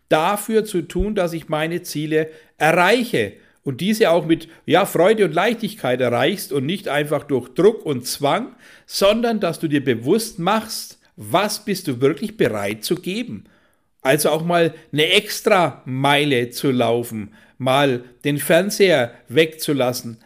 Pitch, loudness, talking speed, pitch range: 160 Hz, -19 LUFS, 145 wpm, 135-200 Hz